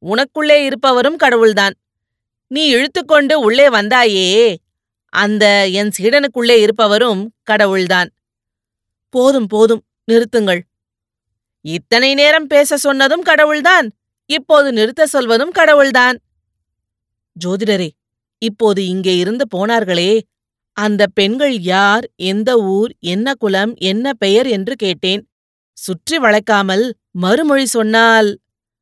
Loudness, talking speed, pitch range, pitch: -12 LUFS, 90 wpm, 185-260 Hz, 215 Hz